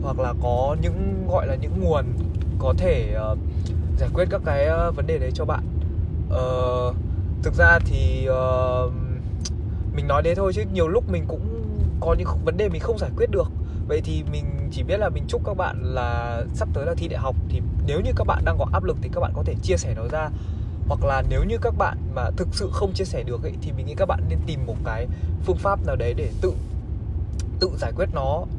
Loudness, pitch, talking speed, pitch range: -24 LUFS, 90 Hz, 235 wpm, 85-95 Hz